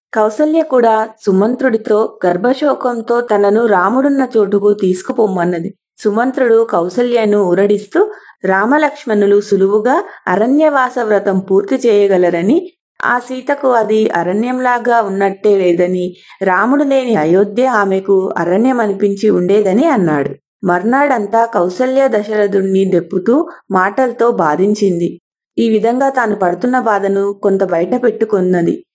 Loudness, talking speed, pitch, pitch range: -13 LUFS, 95 wpm, 215 Hz, 195-250 Hz